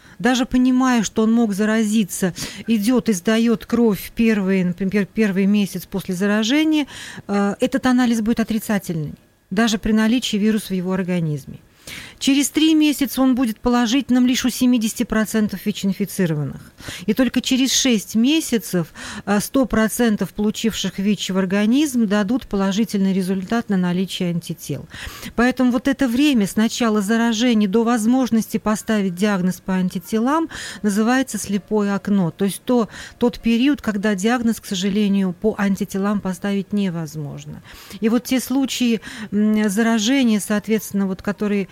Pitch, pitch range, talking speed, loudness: 220 Hz, 200-240 Hz, 130 wpm, -19 LUFS